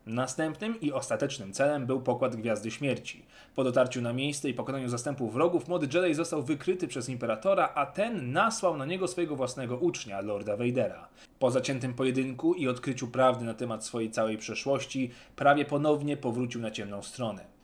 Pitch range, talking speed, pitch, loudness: 125-150 Hz, 165 wpm, 130 Hz, -30 LUFS